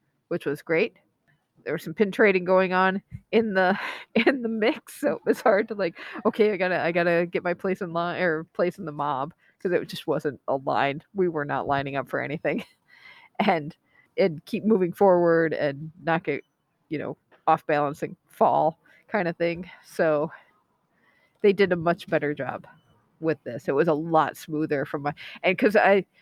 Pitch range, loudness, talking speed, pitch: 155-190 Hz, -25 LUFS, 190 wpm, 170 Hz